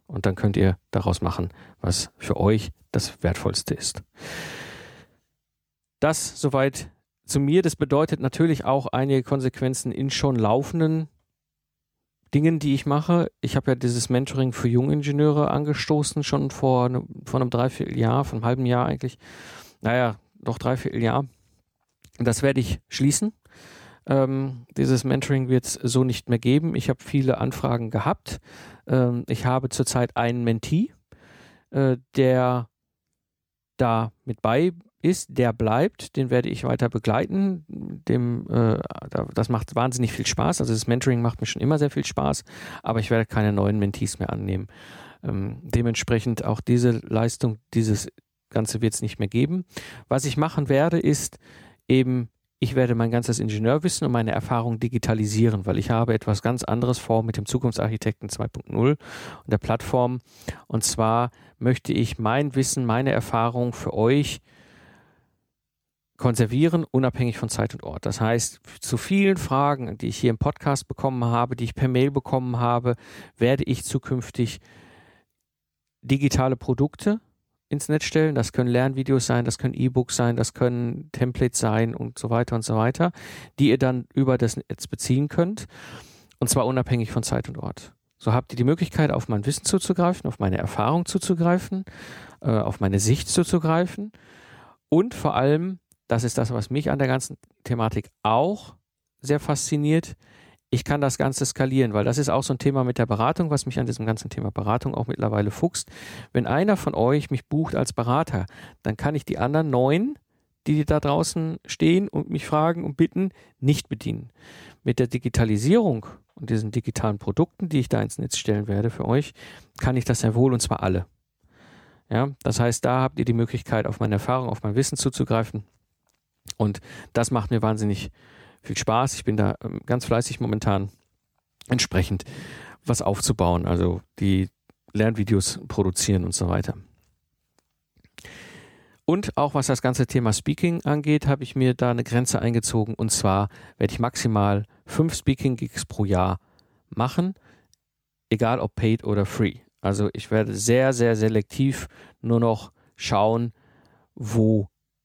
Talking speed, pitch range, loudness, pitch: 160 wpm, 110-140 Hz, -24 LUFS, 120 Hz